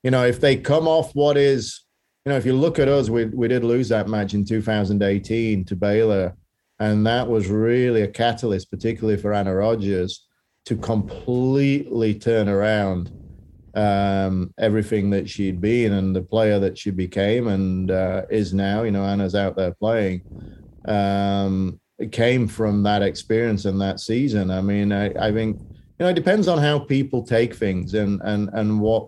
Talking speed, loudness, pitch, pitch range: 180 wpm, -21 LUFS, 105 Hz, 100-115 Hz